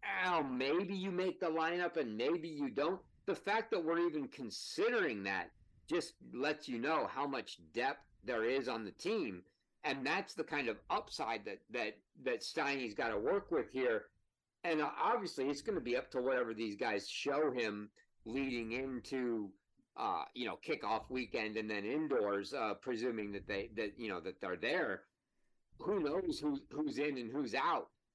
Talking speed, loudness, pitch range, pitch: 180 wpm, -39 LUFS, 115-175 Hz, 140 Hz